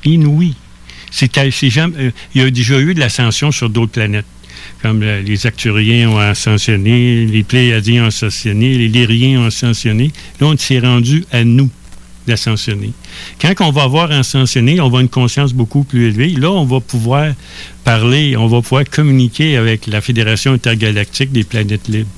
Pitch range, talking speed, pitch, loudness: 110-135 Hz, 175 wpm, 120 Hz, -12 LUFS